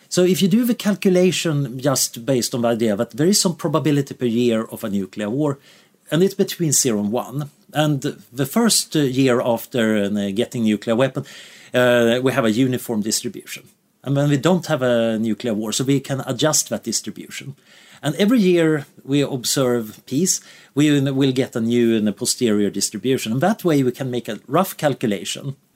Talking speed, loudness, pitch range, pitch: 185 wpm, -19 LUFS, 120-155 Hz, 135 Hz